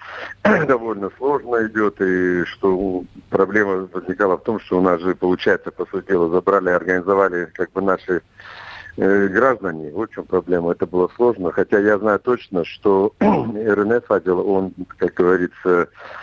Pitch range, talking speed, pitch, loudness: 90-105 Hz, 145 wpm, 95 Hz, -19 LUFS